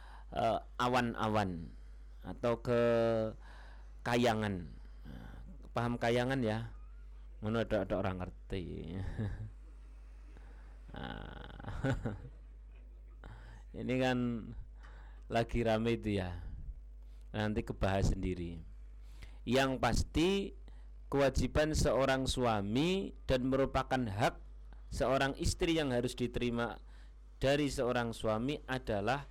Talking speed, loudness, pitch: 80 wpm, -35 LUFS, 110 Hz